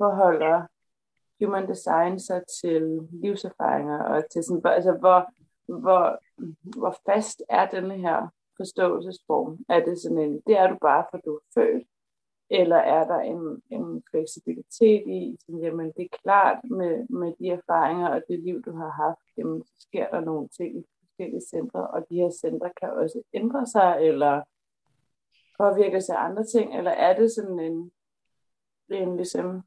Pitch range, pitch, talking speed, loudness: 160-190 Hz, 175 Hz, 165 wpm, -25 LUFS